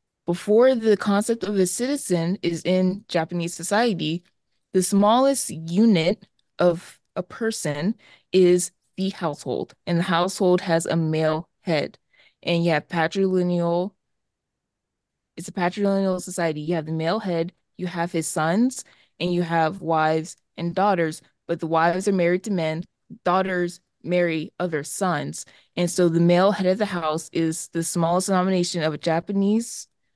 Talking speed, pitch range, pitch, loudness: 150 wpm, 165-195 Hz, 175 Hz, -23 LUFS